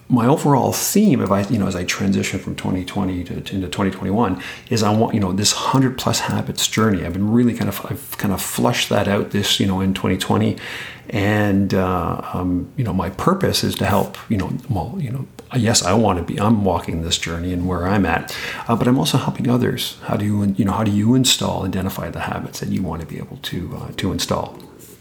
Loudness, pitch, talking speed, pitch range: -19 LUFS, 100 Hz, 230 wpm, 95-115 Hz